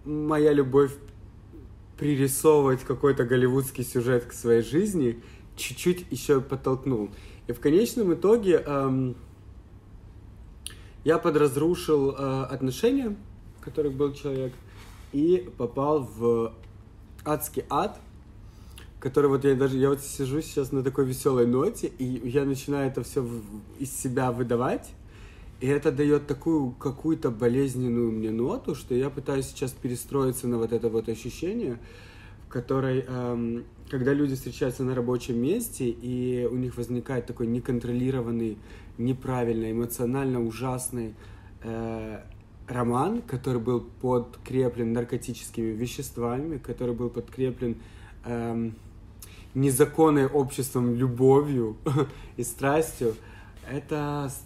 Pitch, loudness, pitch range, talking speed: 125 Hz, -27 LUFS, 115-140 Hz, 115 wpm